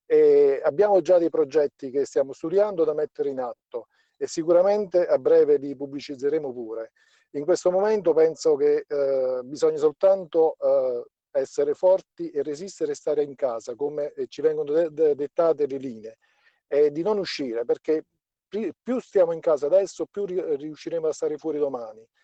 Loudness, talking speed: -24 LUFS, 155 wpm